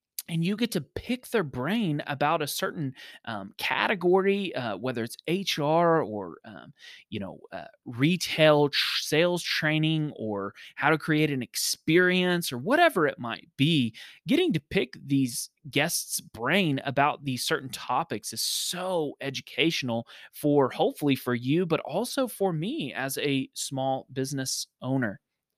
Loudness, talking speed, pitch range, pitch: -27 LUFS, 145 wpm, 135-175 Hz, 150 Hz